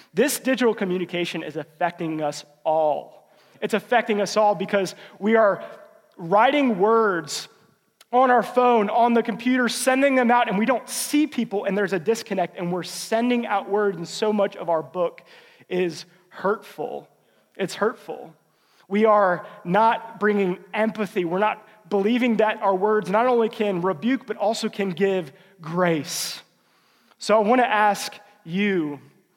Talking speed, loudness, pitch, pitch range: 155 wpm, -22 LUFS, 205 Hz, 180-225 Hz